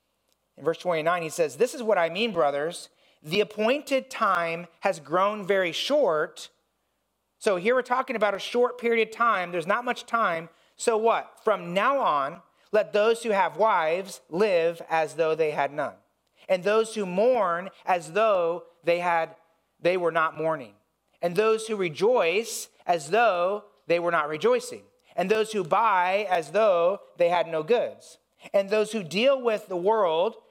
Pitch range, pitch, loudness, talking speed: 170-230 Hz, 200 Hz, -25 LUFS, 170 wpm